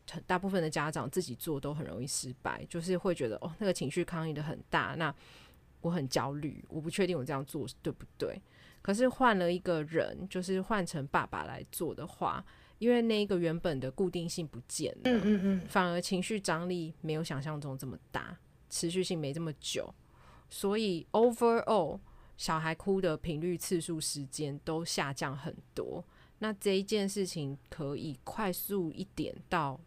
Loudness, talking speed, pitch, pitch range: -34 LUFS, 275 characters per minute, 170 Hz, 145-185 Hz